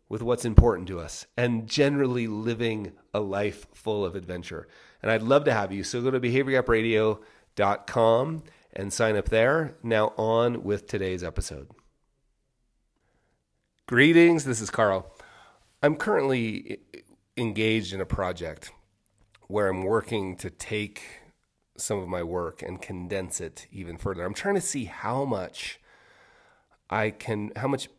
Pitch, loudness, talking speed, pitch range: 110 Hz, -26 LUFS, 140 wpm, 95-120 Hz